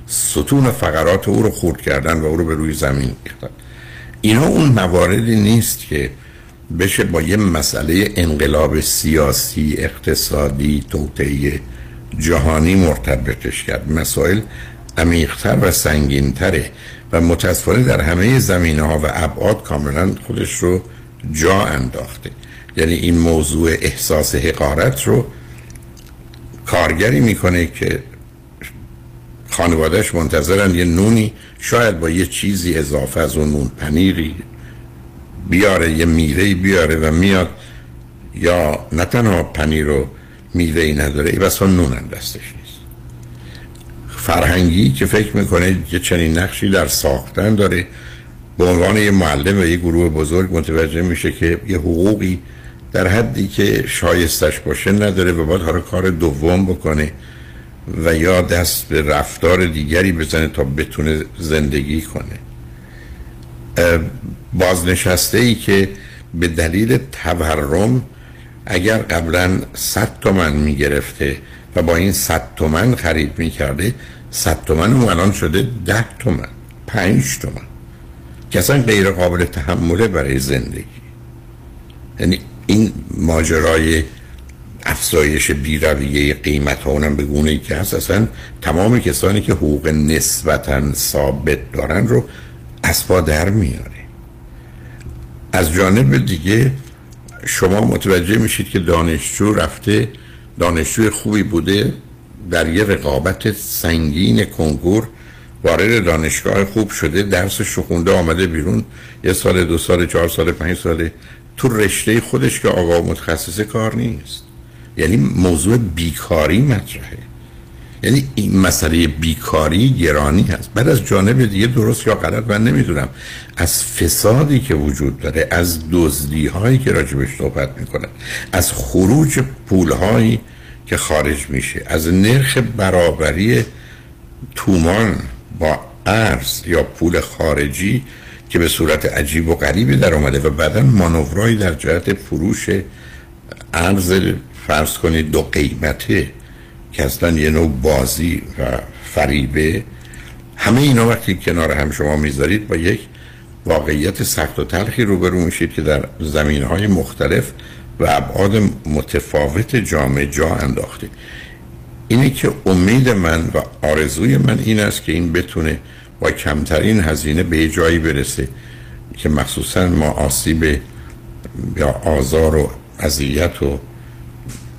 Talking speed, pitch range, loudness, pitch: 125 wpm, 70-95 Hz, -15 LUFS, 80 Hz